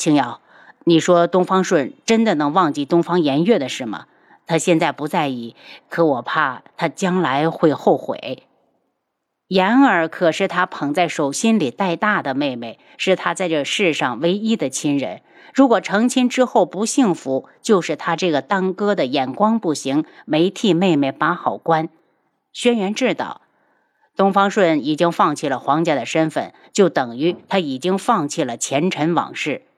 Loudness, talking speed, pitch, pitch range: -18 LUFS, 240 characters per minute, 175 Hz, 155-205 Hz